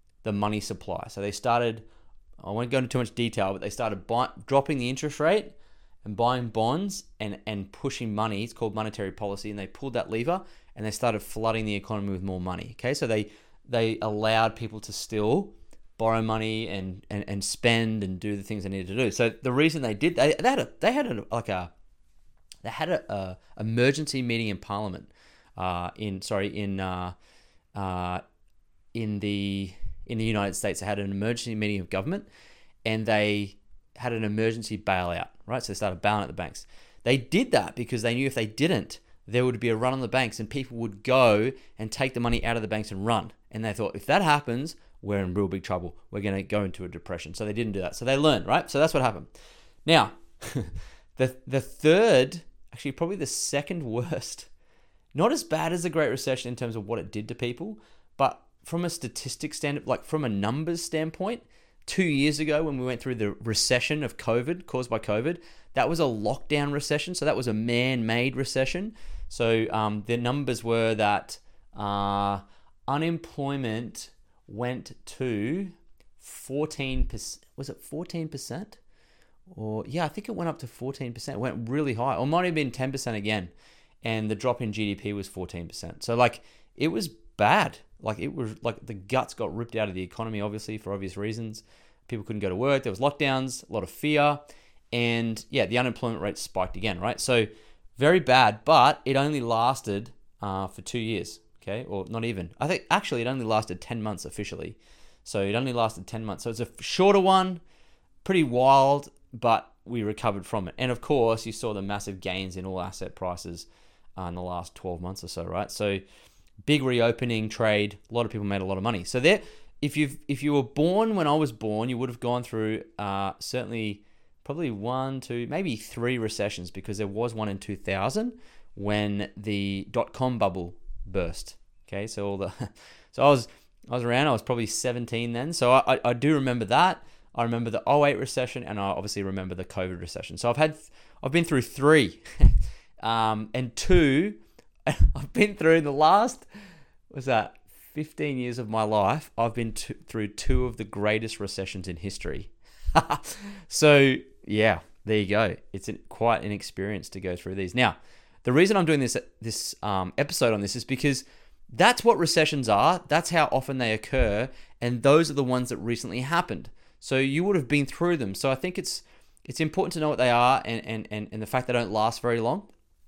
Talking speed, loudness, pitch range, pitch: 200 wpm, -27 LUFS, 100-130 Hz, 115 Hz